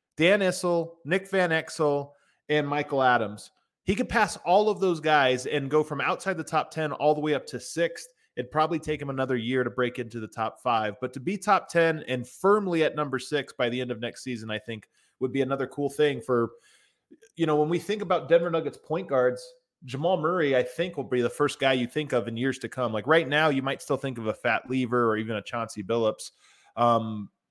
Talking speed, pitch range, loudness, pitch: 235 wpm, 125-165 Hz, -26 LUFS, 145 Hz